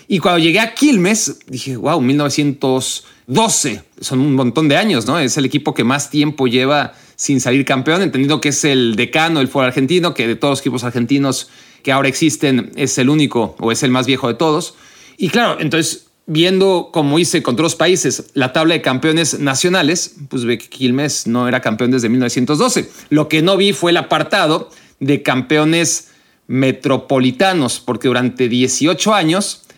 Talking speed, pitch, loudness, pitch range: 180 wpm, 140 Hz, -15 LUFS, 130-160 Hz